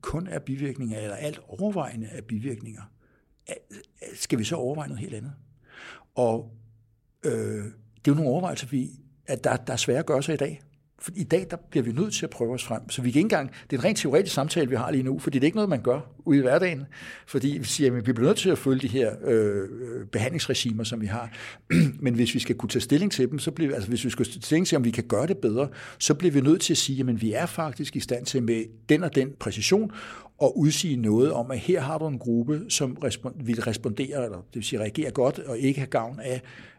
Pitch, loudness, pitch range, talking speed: 130 Hz, -26 LUFS, 115-150 Hz, 250 wpm